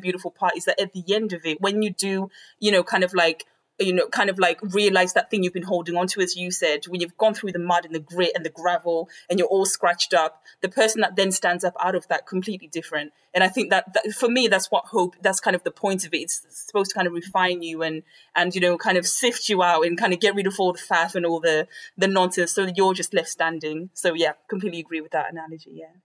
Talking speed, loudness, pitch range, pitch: 280 wpm, -22 LUFS, 170-195 Hz, 180 Hz